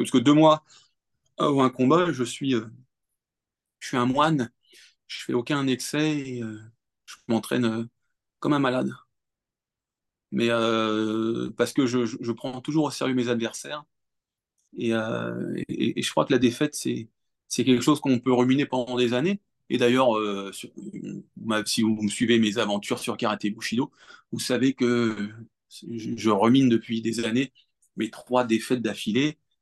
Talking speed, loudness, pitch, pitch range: 170 wpm, -25 LUFS, 120 Hz, 115-130 Hz